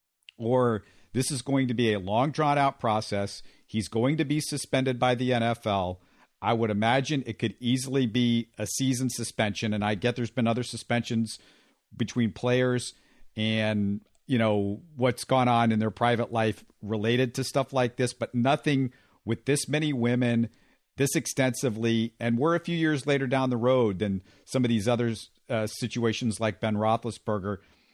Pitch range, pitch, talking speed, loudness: 110-130 Hz, 120 Hz, 170 wpm, -27 LUFS